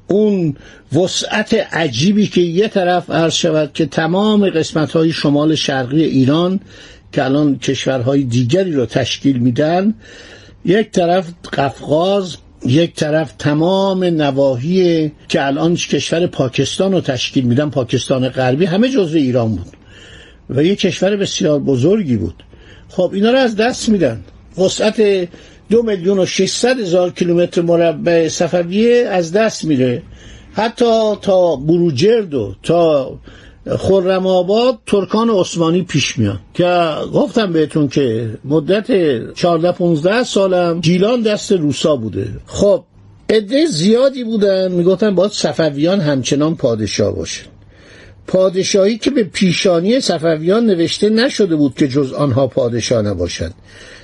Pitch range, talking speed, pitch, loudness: 135-195 Hz, 120 wpm, 170 Hz, -15 LUFS